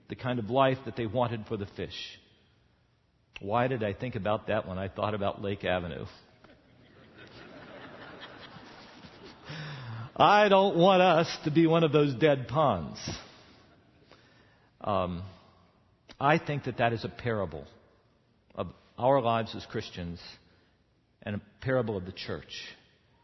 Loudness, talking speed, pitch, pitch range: -28 LUFS, 135 wpm, 115 Hz, 100-135 Hz